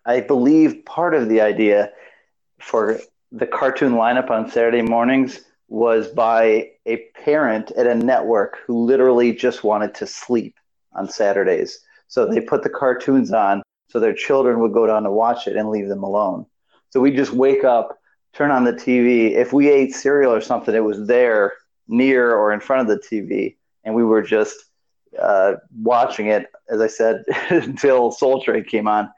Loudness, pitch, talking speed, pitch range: -18 LUFS, 120 Hz, 180 wpm, 110-135 Hz